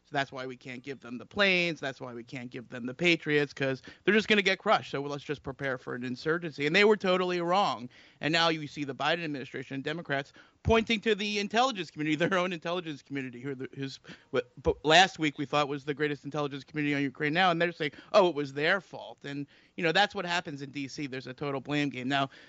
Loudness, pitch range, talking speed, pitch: -29 LUFS, 135-175 Hz, 245 wpm, 145 Hz